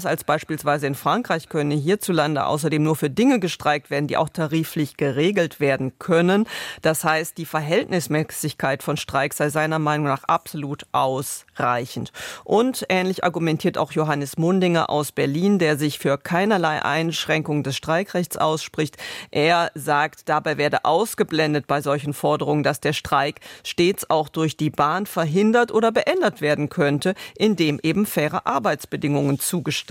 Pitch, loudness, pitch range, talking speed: 155 Hz, -21 LUFS, 145-170 Hz, 145 wpm